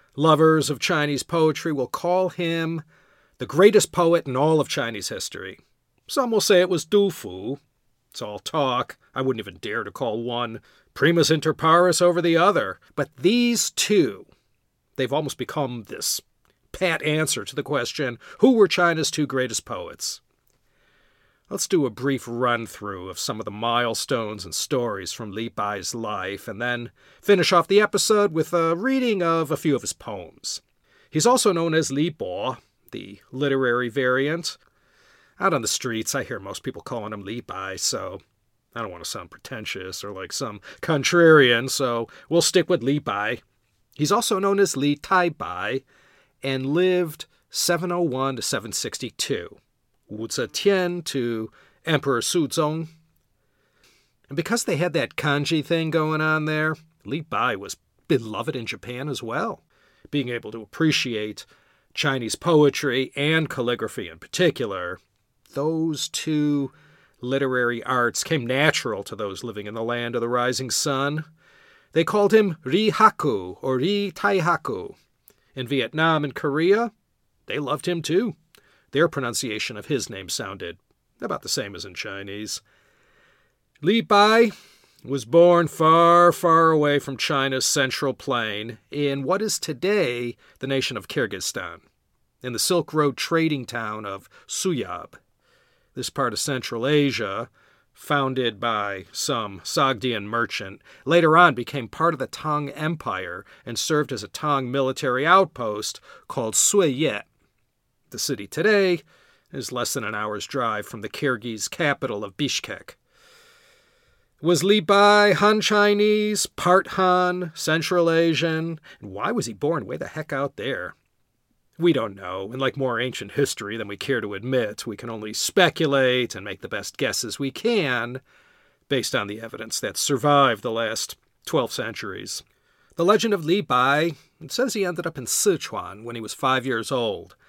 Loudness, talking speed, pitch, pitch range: -23 LUFS, 155 wpm, 145 Hz, 120-170 Hz